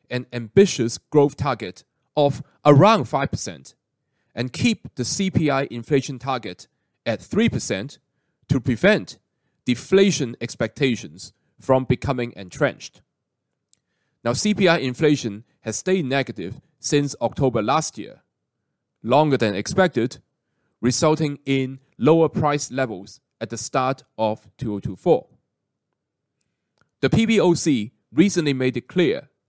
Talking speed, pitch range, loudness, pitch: 105 wpm, 120-150 Hz, -21 LUFS, 135 Hz